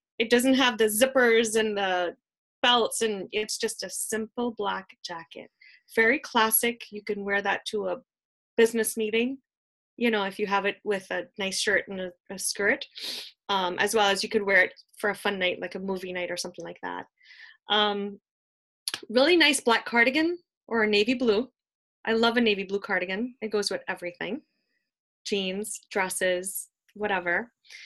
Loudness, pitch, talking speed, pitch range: -26 LUFS, 210 Hz, 170 wpm, 195-235 Hz